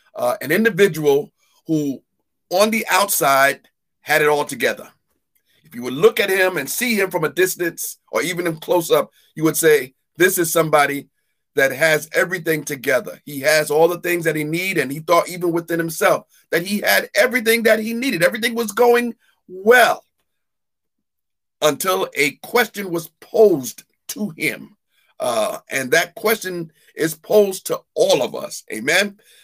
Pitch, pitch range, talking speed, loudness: 175 Hz, 155-215 Hz, 165 wpm, -18 LUFS